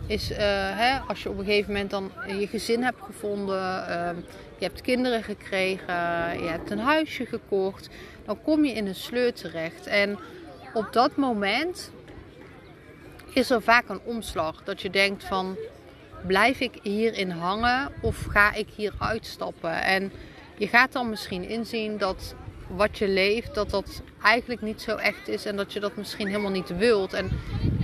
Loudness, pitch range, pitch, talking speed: -26 LUFS, 190-230 Hz, 205 Hz, 170 wpm